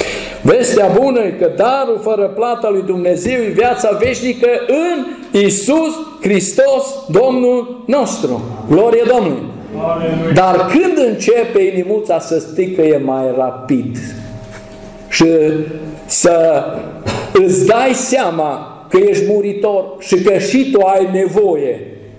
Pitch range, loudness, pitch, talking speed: 165-255 Hz, -13 LUFS, 205 Hz, 115 wpm